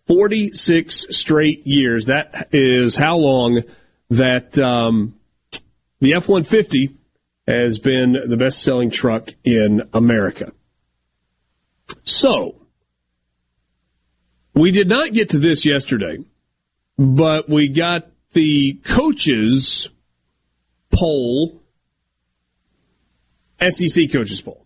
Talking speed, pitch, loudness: 90 wpm, 130 Hz, -16 LUFS